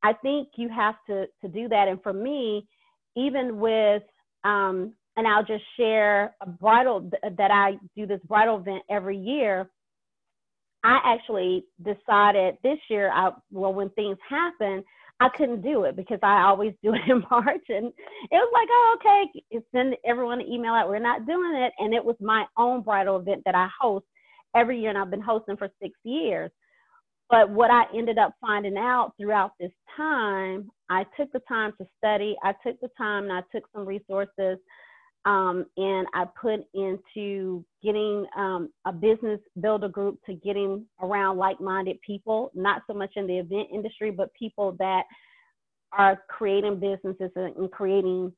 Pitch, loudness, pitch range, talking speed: 210 Hz, -25 LUFS, 195-235 Hz, 175 wpm